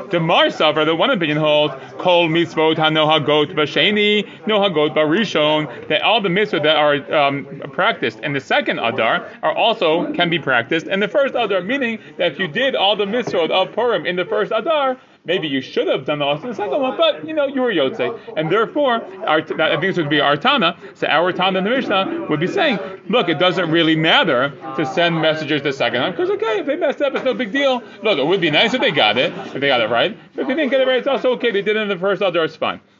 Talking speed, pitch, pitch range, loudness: 255 wpm, 190 Hz, 155-245 Hz, -17 LUFS